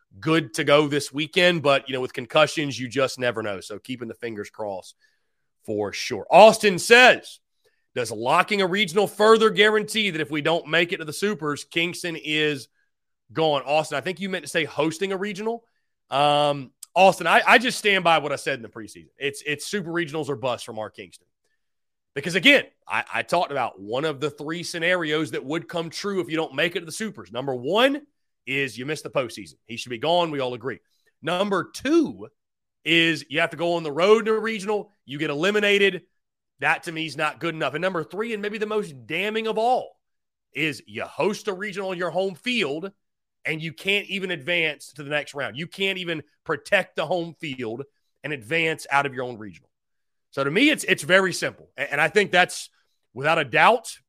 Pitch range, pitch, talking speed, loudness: 145-200 Hz, 165 Hz, 210 wpm, -22 LUFS